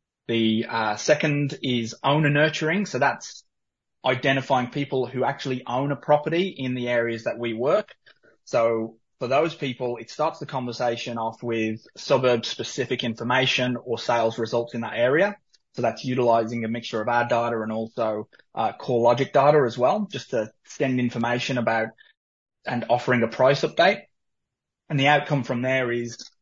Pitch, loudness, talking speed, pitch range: 125 Hz, -24 LUFS, 165 wpm, 115-135 Hz